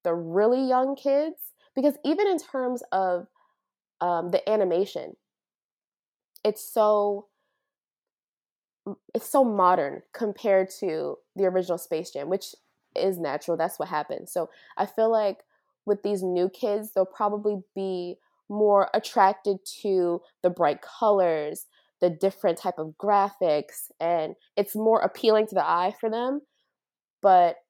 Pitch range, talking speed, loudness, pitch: 180-235 Hz, 130 wpm, -26 LUFS, 200 Hz